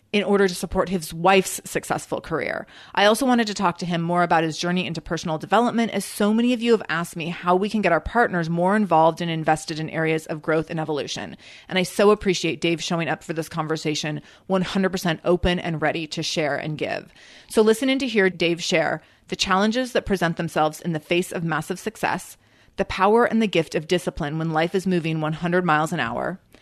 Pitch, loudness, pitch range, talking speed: 175 Hz, -22 LUFS, 160-195 Hz, 220 wpm